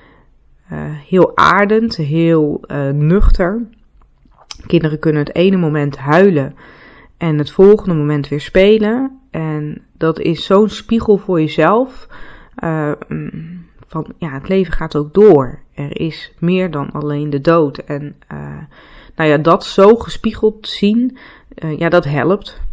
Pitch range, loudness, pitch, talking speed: 150-200 Hz, -14 LUFS, 165 Hz, 135 wpm